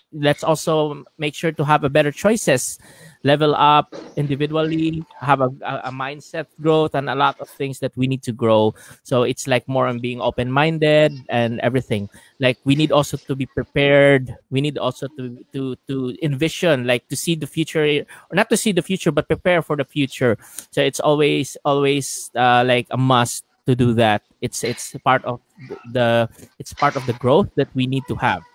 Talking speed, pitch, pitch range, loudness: 195 wpm, 140 Hz, 125-150 Hz, -19 LUFS